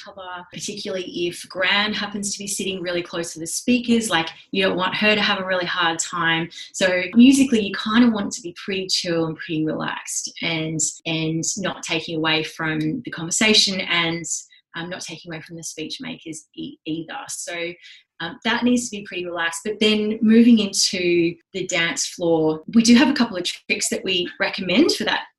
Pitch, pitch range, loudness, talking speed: 185 Hz, 165-215 Hz, -20 LUFS, 200 wpm